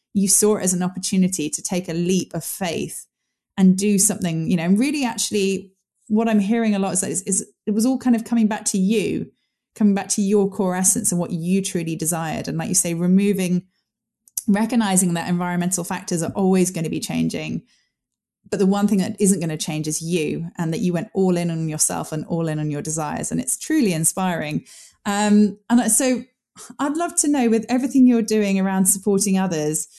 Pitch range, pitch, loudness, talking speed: 175-215 Hz, 195 Hz, -20 LUFS, 210 wpm